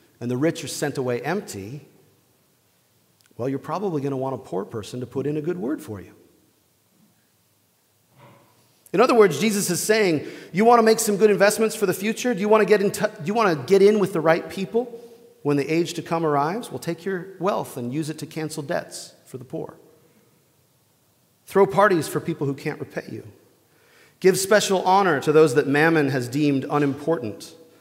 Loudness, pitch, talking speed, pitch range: -22 LUFS, 165 Hz, 205 wpm, 145-205 Hz